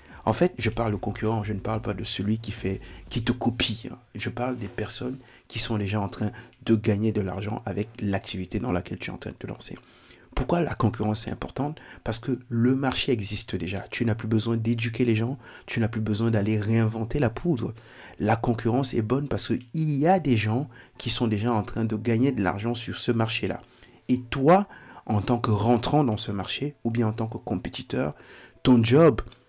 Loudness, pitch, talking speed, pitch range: -26 LUFS, 115 Hz, 220 wpm, 105-125 Hz